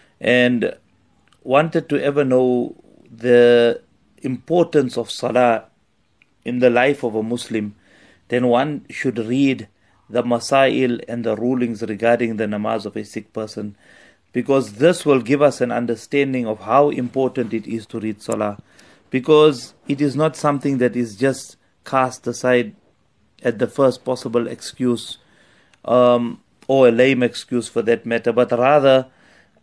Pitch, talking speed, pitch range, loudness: 125 Hz, 145 wpm, 115-135 Hz, -18 LUFS